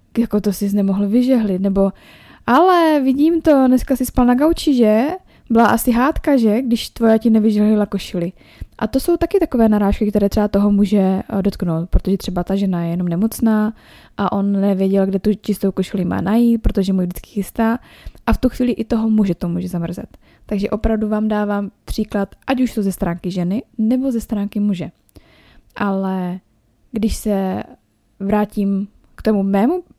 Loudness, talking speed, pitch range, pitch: -17 LUFS, 175 wpm, 195-235 Hz, 210 Hz